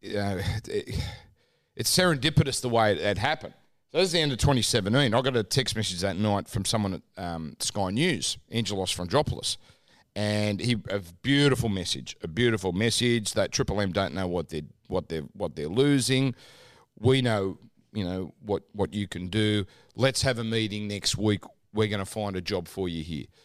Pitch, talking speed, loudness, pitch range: 105 Hz, 190 wpm, -27 LUFS, 95-120 Hz